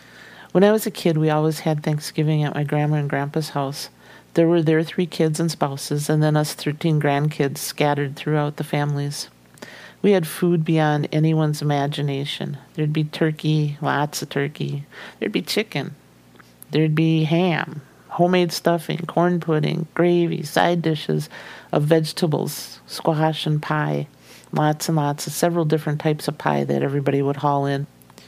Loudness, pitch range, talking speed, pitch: -21 LUFS, 145-160 Hz, 160 wpm, 150 Hz